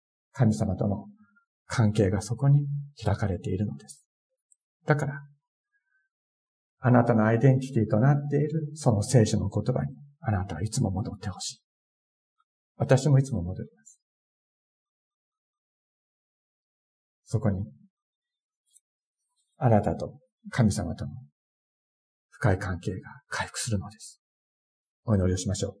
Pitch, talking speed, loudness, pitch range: 125 Hz, 235 characters per minute, -27 LUFS, 105-155 Hz